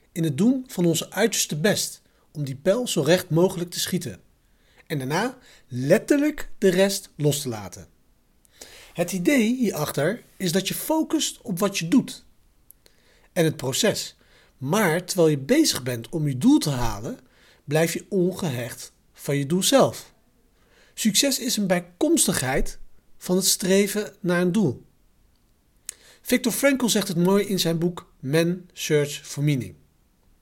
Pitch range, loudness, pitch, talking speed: 150-210 Hz, -23 LUFS, 180 Hz, 150 wpm